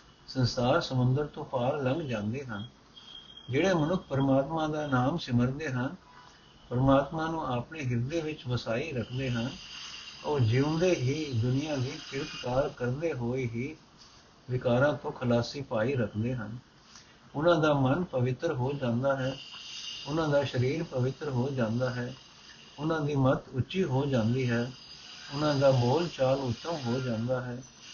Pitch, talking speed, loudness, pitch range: 130 Hz, 140 wpm, -30 LUFS, 125-150 Hz